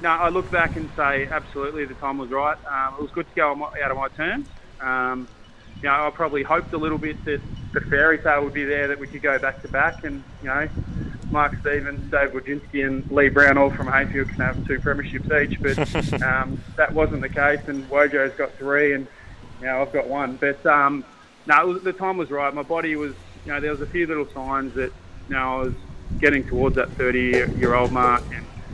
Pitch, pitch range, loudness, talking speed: 140 Hz, 130-150 Hz, -22 LUFS, 225 wpm